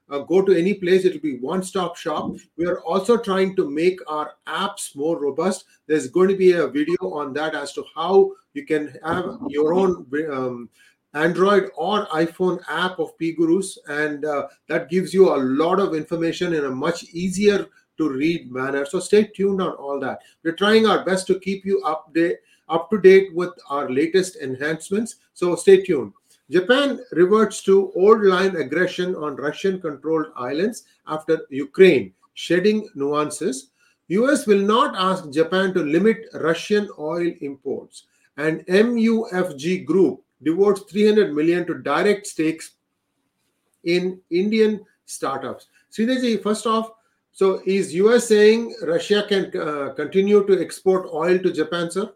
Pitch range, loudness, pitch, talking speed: 160-210 Hz, -20 LUFS, 185 Hz, 160 wpm